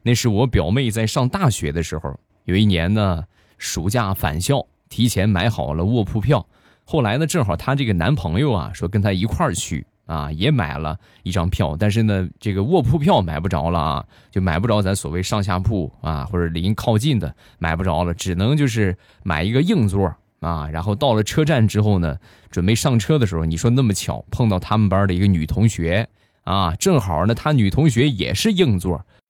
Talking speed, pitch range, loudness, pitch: 290 characters per minute, 85-115 Hz, -20 LUFS, 100 Hz